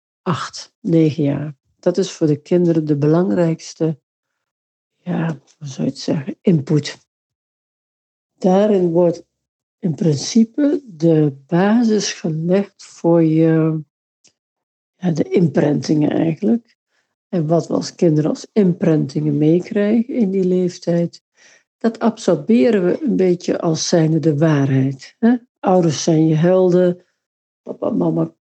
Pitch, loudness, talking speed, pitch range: 170 Hz, -17 LUFS, 115 wpm, 155-195 Hz